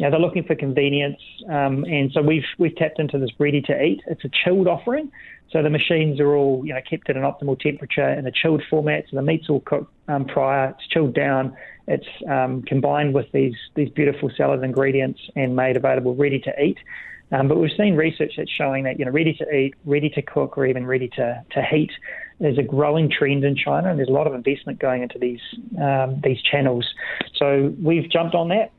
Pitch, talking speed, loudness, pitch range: 145 Hz, 220 wpm, -21 LUFS, 135-155 Hz